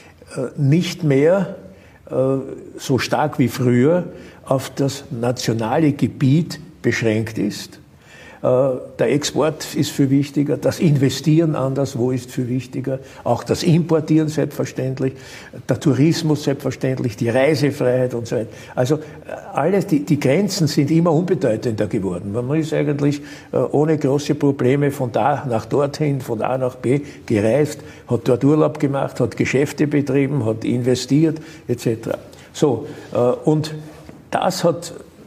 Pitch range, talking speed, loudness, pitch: 125-155 Hz, 130 wpm, -19 LUFS, 140 Hz